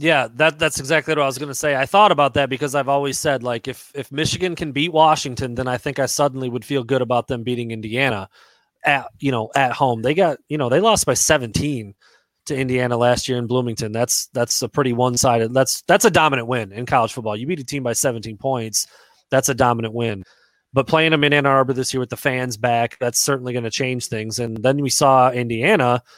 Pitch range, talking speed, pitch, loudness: 120-140 Hz, 235 wpm, 130 Hz, -19 LUFS